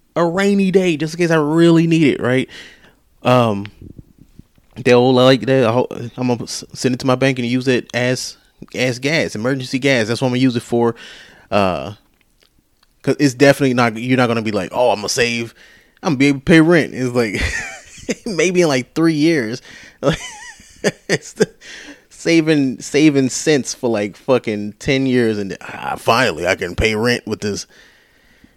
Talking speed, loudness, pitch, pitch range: 175 wpm, -16 LUFS, 130 Hz, 120-145 Hz